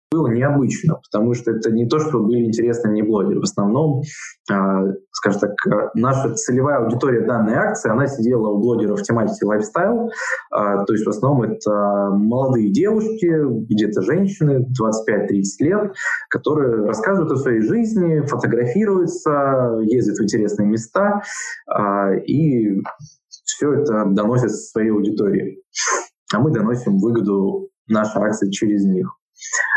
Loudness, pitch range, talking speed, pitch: -18 LUFS, 105-155 Hz, 125 wpm, 115 Hz